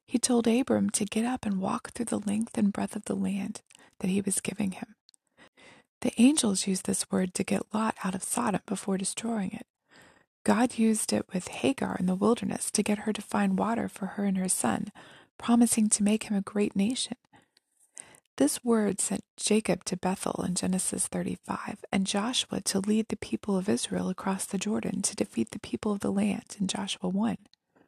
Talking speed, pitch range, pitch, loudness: 195 wpm, 195-230 Hz, 210 Hz, -29 LUFS